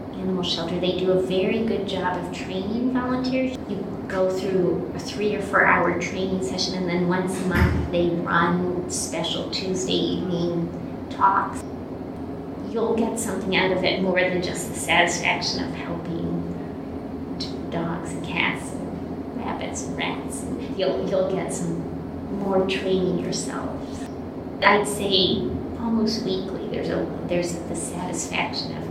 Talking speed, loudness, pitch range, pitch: 145 wpm, -24 LUFS, 175-205 Hz, 185 Hz